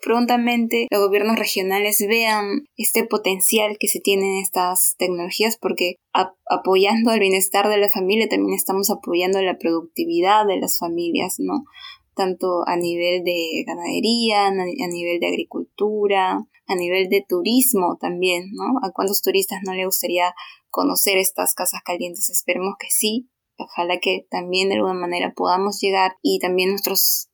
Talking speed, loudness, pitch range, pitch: 150 wpm, -19 LUFS, 180-215 Hz, 195 Hz